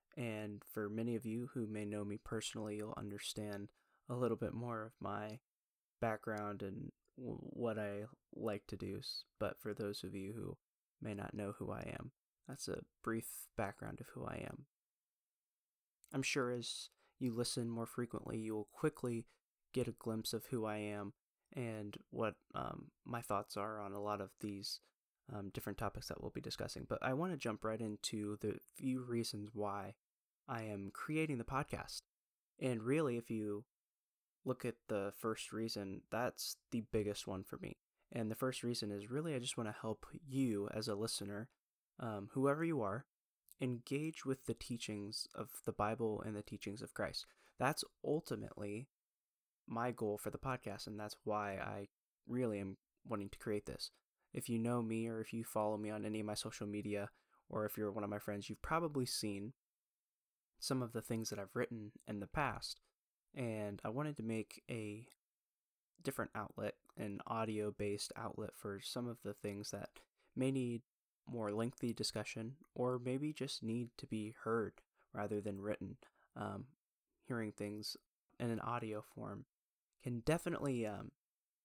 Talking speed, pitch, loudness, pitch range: 175 wpm, 110 Hz, -44 LUFS, 105-120 Hz